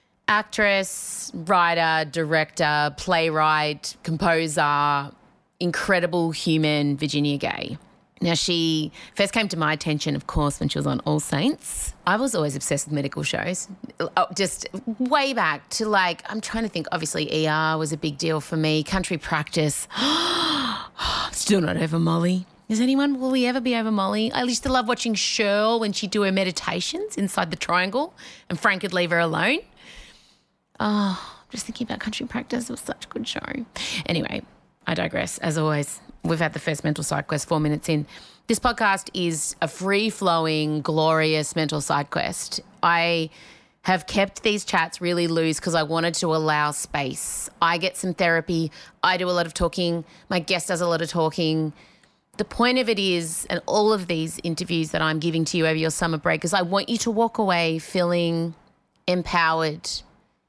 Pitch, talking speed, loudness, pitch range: 170 Hz, 175 wpm, -23 LUFS, 160-205 Hz